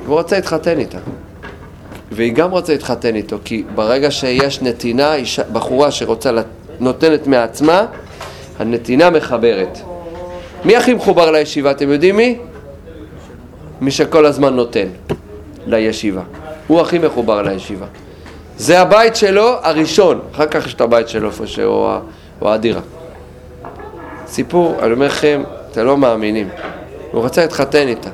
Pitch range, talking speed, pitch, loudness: 105-155 Hz, 130 wpm, 135 Hz, -14 LUFS